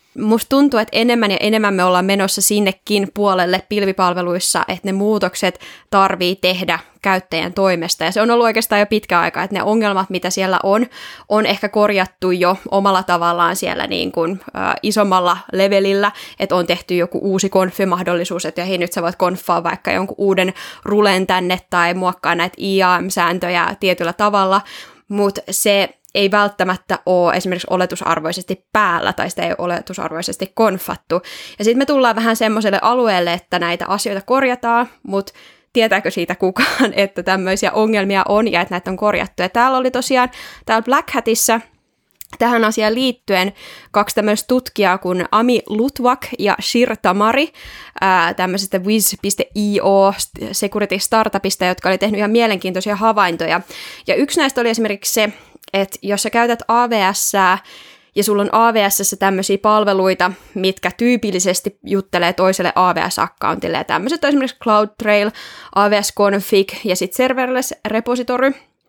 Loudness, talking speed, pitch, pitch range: -16 LUFS, 145 wpm, 200 Hz, 185-220 Hz